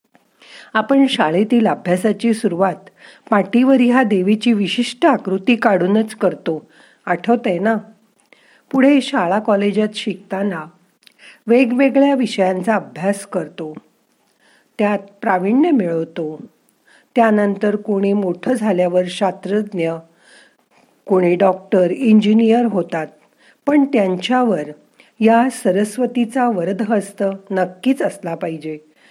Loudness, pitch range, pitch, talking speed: -17 LUFS, 185-235 Hz, 205 Hz, 85 wpm